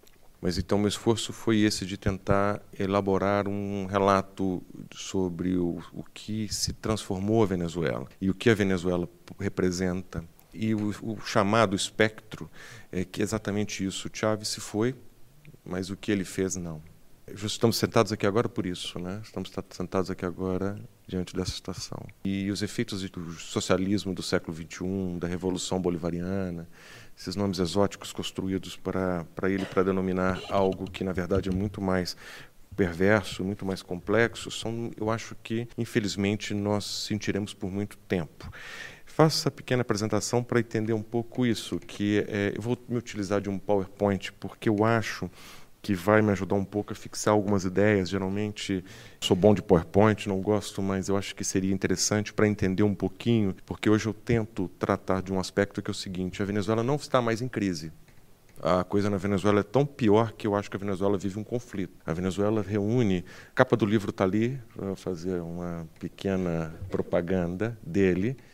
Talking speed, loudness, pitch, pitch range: 170 wpm, -28 LUFS, 100 Hz, 95-110 Hz